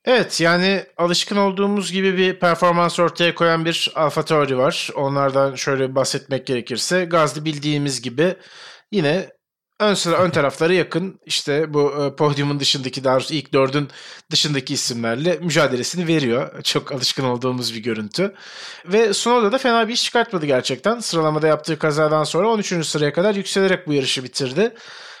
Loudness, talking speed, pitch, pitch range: -19 LUFS, 145 wpm, 155 Hz, 140-180 Hz